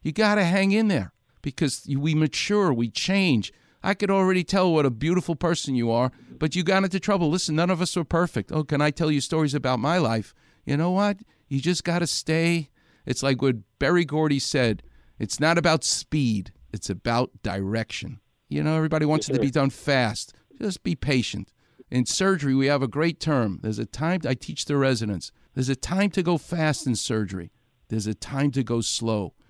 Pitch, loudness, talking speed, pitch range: 145 Hz, -24 LUFS, 210 wpm, 120-170 Hz